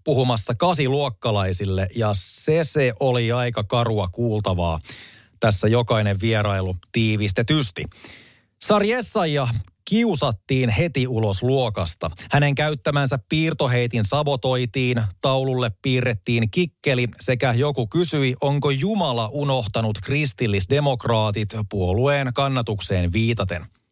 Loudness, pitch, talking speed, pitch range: -21 LUFS, 125 Hz, 90 wpm, 110-140 Hz